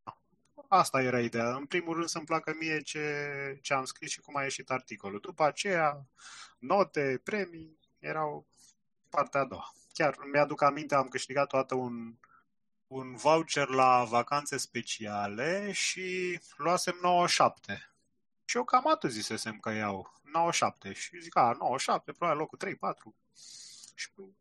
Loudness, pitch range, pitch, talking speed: -31 LUFS, 130-180 Hz, 145 Hz, 140 wpm